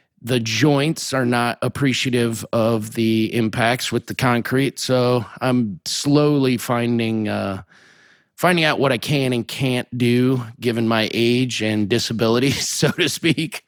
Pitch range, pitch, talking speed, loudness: 115-130 Hz, 120 Hz, 140 wpm, -19 LUFS